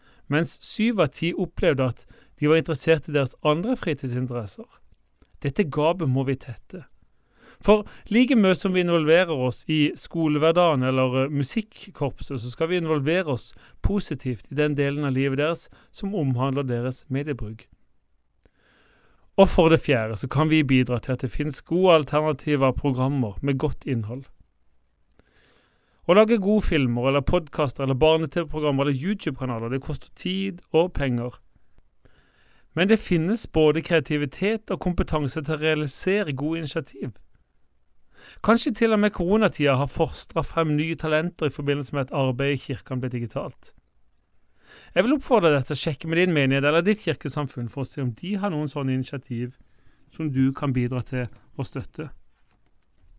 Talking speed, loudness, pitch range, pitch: 155 wpm, -24 LUFS, 130-165 Hz, 150 Hz